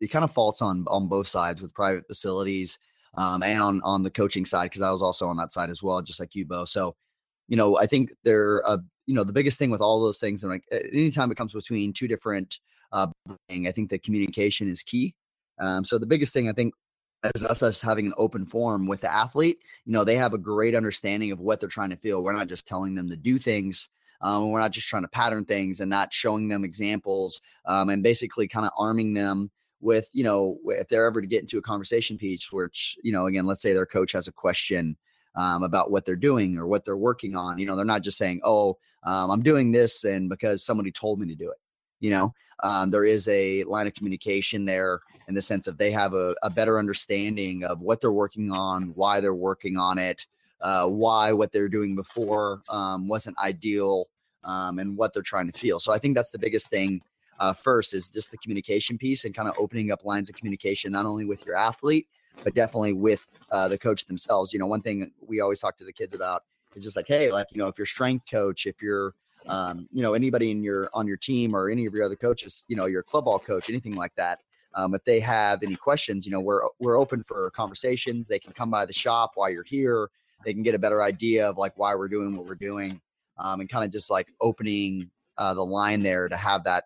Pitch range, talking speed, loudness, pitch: 95-110 Hz, 245 wpm, -26 LUFS, 100 Hz